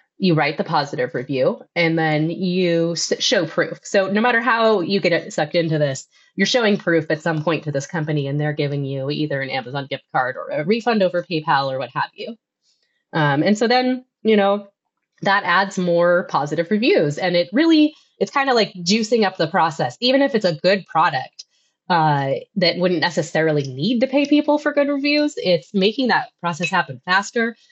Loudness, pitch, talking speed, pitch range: -19 LUFS, 180 Hz, 200 wpm, 155-230 Hz